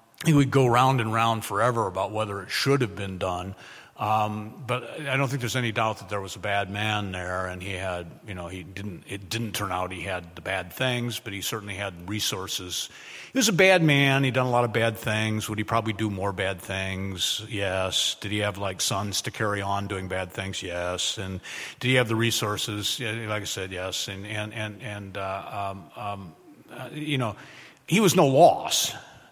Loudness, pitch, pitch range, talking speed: -26 LUFS, 105 Hz, 95-115 Hz, 215 wpm